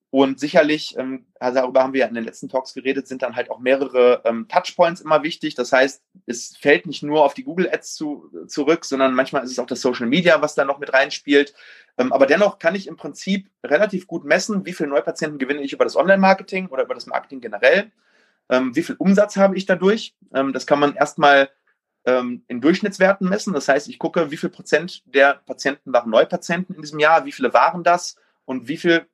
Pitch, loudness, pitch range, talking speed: 155 Hz, -19 LUFS, 135-190 Hz, 205 wpm